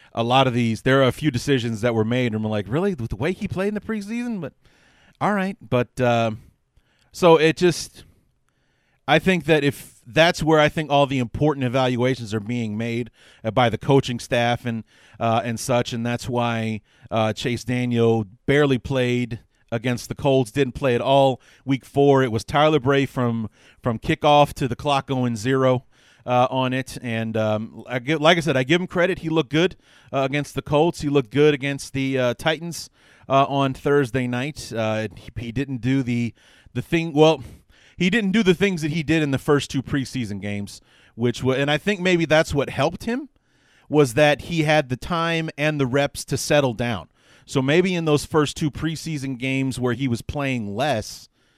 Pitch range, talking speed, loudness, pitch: 120-150 Hz, 200 wpm, -21 LUFS, 135 Hz